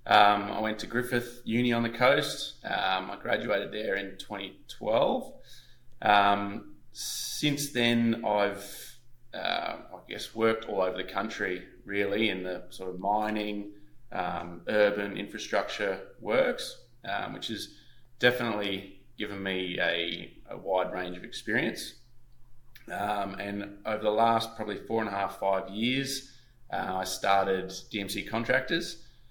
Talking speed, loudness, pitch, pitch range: 135 wpm, -30 LUFS, 105 Hz, 100-120 Hz